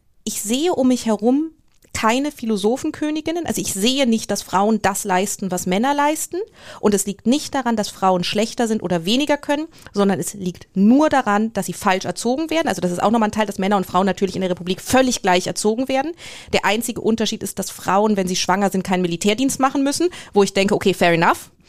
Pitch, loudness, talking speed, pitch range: 210 Hz, -19 LUFS, 220 wpm, 190-260 Hz